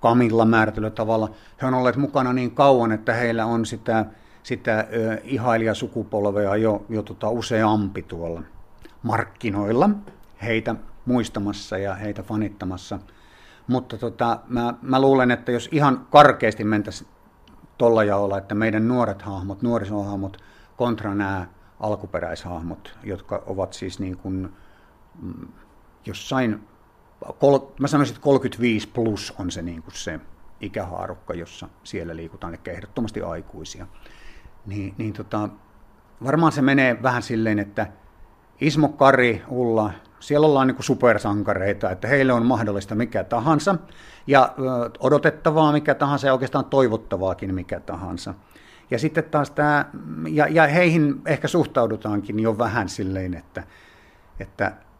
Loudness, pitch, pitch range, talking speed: -22 LUFS, 110 Hz, 100-125 Hz, 125 wpm